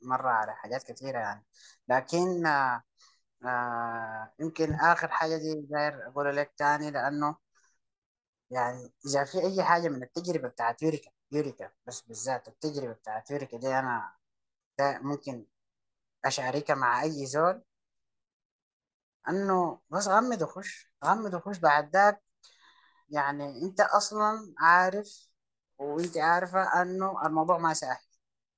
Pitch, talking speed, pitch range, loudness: 155 Hz, 120 wpm, 135-180 Hz, -29 LUFS